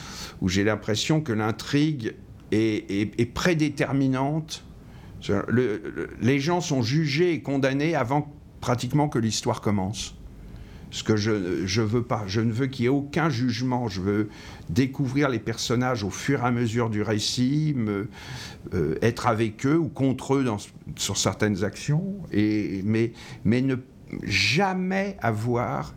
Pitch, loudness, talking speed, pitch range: 120 Hz, -25 LUFS, 155 wpm, 105-140 Hz